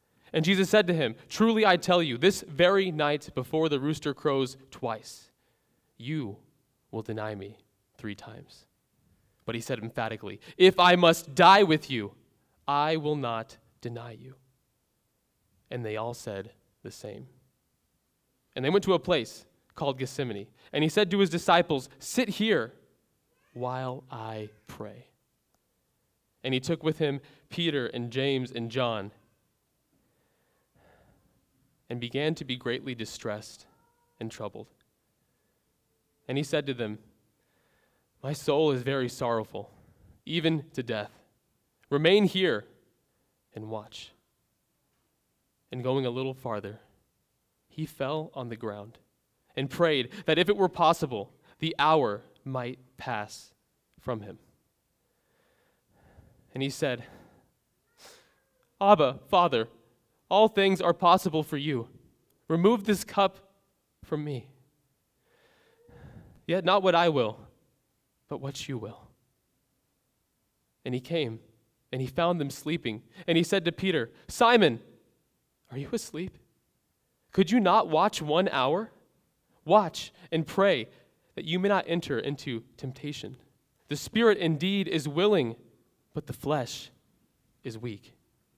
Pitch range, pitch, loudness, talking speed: 115-170 Hz, 140 Hz, -27 LUFS, 130 wpm